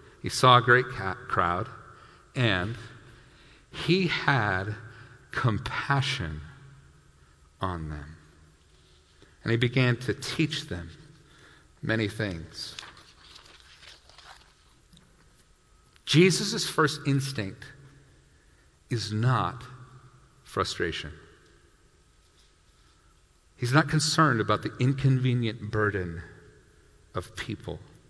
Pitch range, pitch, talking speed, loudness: 80-130 Hz, 105 Hz, 75 wpm, -27 LUFS